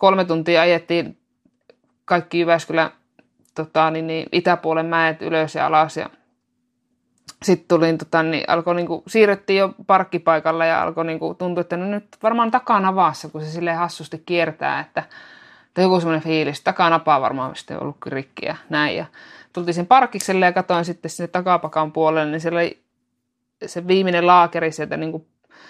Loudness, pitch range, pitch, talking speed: -19 LUFS, 160-185 Hz, 170 Hz, 165 wpm